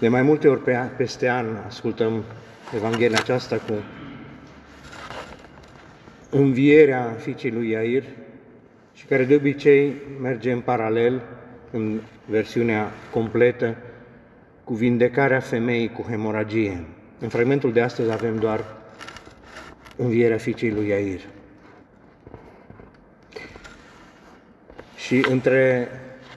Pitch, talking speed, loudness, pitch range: 120 Hz, 95 wpm, -22 LUFS, 110-130 Hz